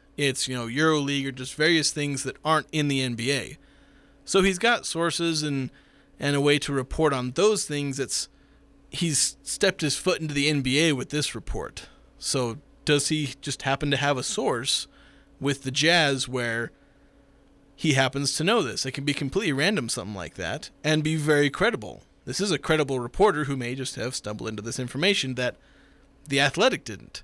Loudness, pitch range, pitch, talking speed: -25 LUFS, 130-155 Hz, 140 Hz, 185 wpm